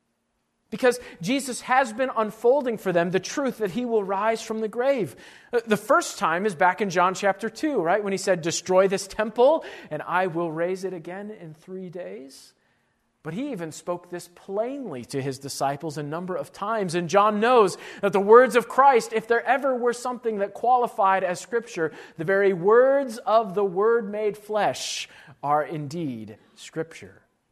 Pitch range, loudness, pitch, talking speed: 175-235 Hz, -23 LUFS, 205 Hz, 180 wpm